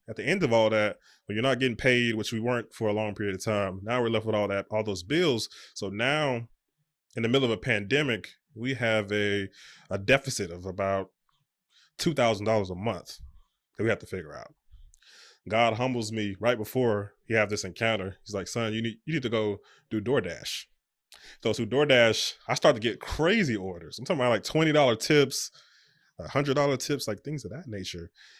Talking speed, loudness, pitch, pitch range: 210 wpm, -27 LUFS, 110 Hz, 105-130 Hz